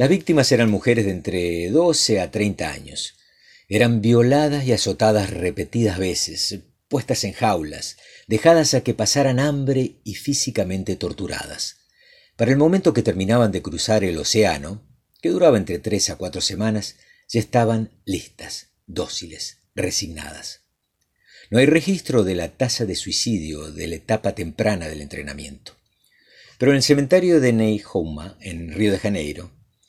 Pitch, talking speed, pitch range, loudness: 110 Hz, 145 wpm, 95-125 Hz, -20 LUFS